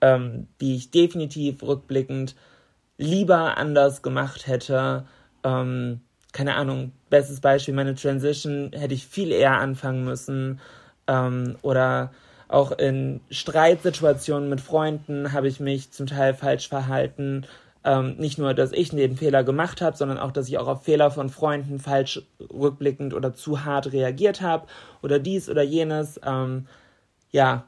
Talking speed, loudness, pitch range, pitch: 145 wpm, -24 LUFS, 130-145 Hz, 140 Hz